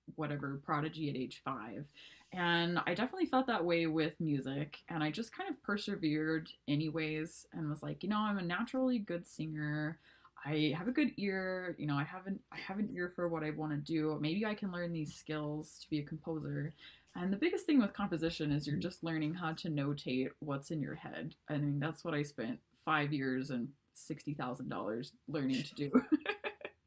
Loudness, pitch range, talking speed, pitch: -38 LUFS, 150-180 Hz, 205 wpm, 155 Hz